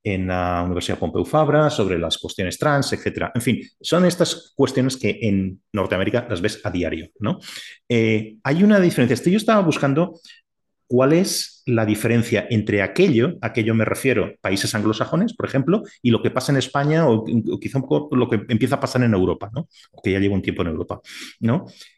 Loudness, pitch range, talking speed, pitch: -20 LUFS, 105-145 Hz, 200 wpm, 115 Hz